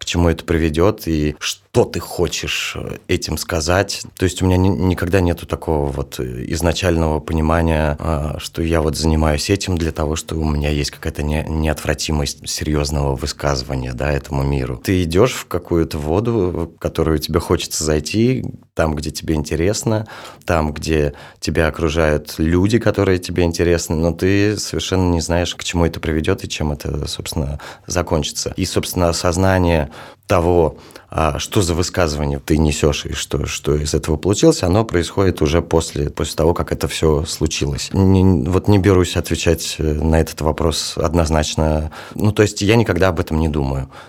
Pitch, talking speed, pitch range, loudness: 80 Hz, 160 wpm, 75-90 Hz, -18 LUFS